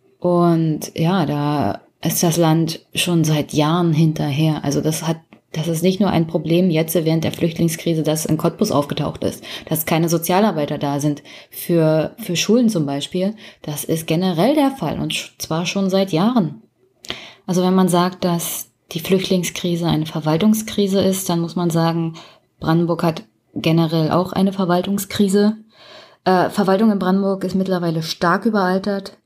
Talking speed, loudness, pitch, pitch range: 160 wpm, -18 LUFS, 170 Hz, 160-190 Hz